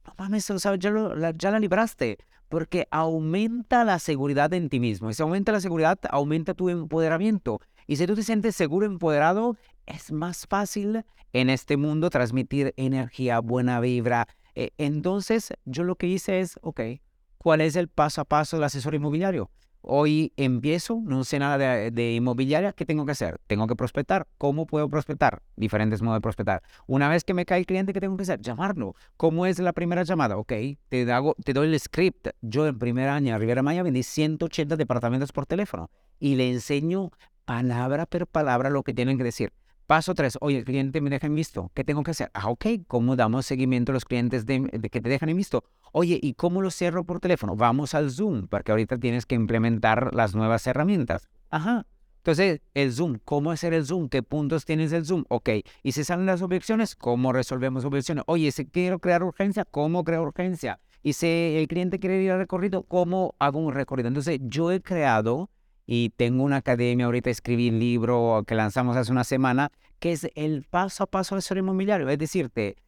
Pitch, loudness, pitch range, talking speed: 150 Hz, -25 LUFS, 125-180 Hz, 195 wpm